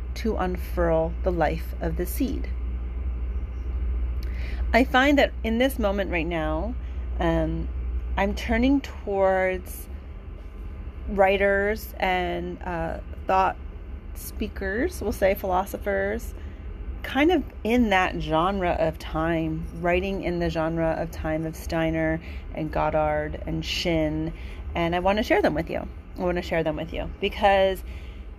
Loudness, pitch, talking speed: -25 LUFS, 160 Hz, 130 wpm